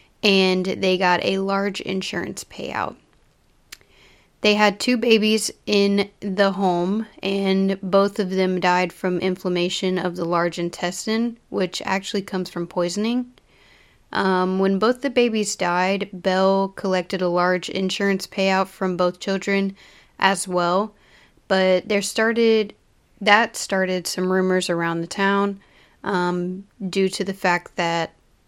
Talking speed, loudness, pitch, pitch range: 135 wpm, -21 LUFS, 190 Hz, 180-200 Hz